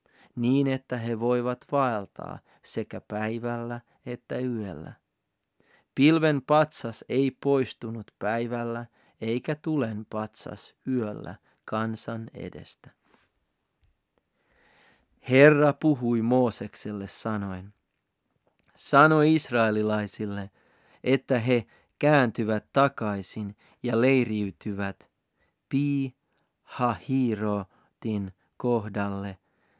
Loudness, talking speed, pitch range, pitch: -26 LUFS, 70 wpm, 105-130 Hz, 115 Hz